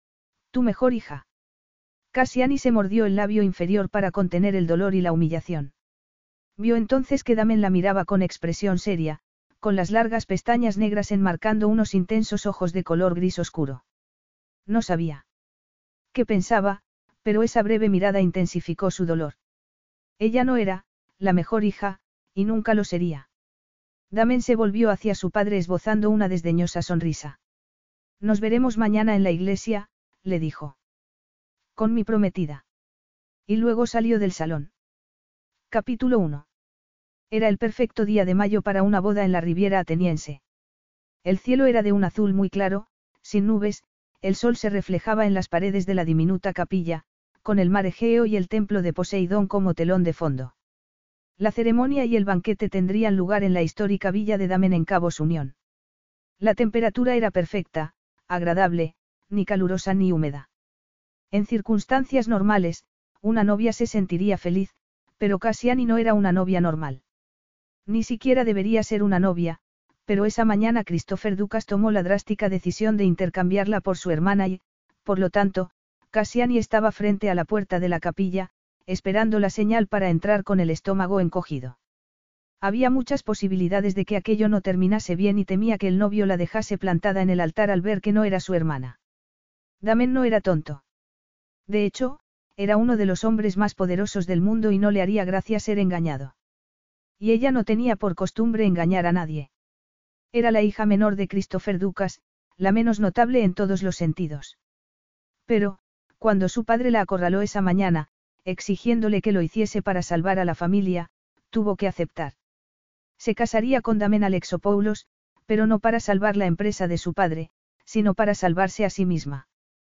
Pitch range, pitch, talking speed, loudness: 180-215 Hz, 200 Hz, 165 wpm, -23 LUFS